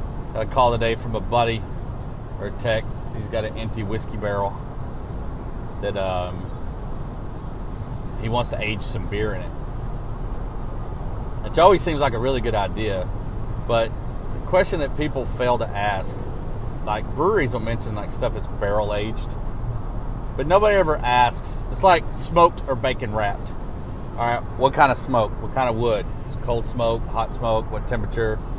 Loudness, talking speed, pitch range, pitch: -24 LUFS, 155 wpm, 110-125 Hz, 115 Hz